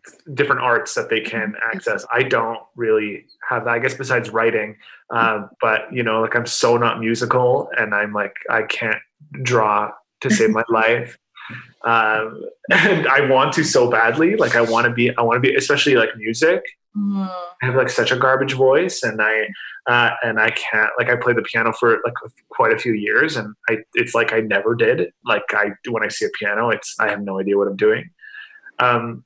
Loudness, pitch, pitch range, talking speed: -18 LUFS, 120 Hz, 115-185 Hz, 205 wpm